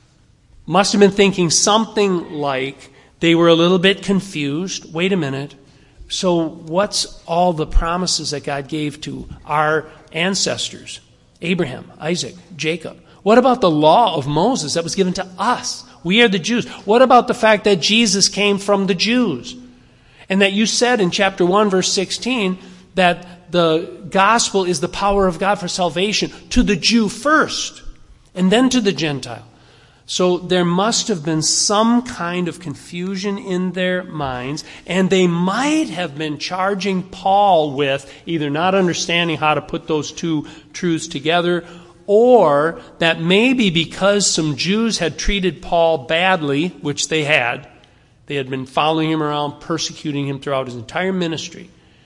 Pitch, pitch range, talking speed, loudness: 175 Hz, 155-195 Hz, 160 wpm, -17 LUFS